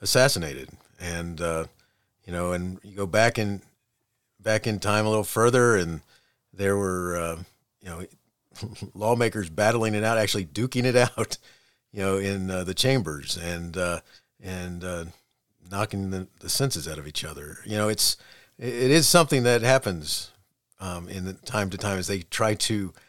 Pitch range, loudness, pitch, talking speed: 90-110 Hz, -25 LUFS, 100 Hz, 170 wpm